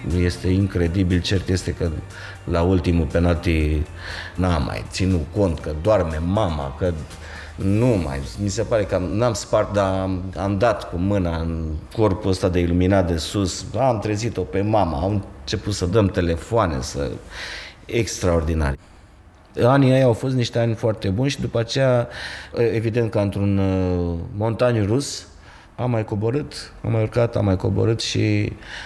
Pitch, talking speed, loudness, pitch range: 95 Hz, 150 wpm, -21 LUFS, 85-110 Hz